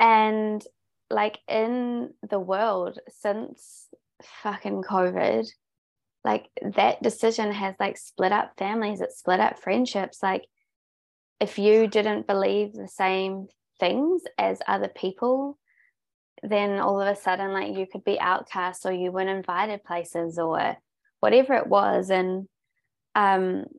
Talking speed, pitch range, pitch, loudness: 130 wpm, 185-220 Hz, 200 Hz, -25 LUFS